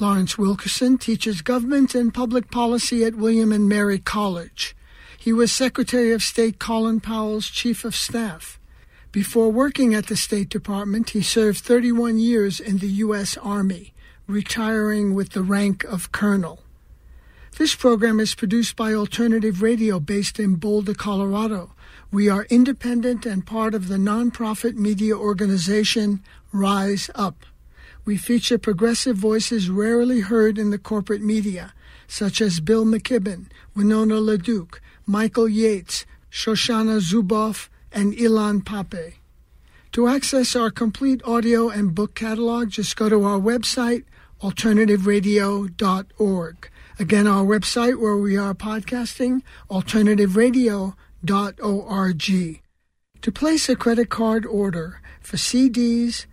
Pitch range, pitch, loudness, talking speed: 200-230 Hz, 215 Hz, -21 LUFS, 125 wpm